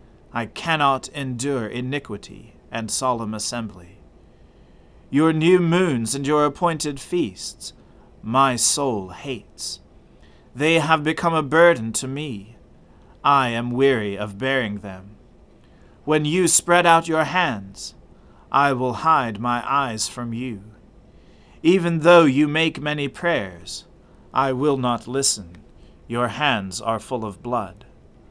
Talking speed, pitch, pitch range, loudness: 125 wpm, 125 Hz, 110-150 Hz, -21 LUFS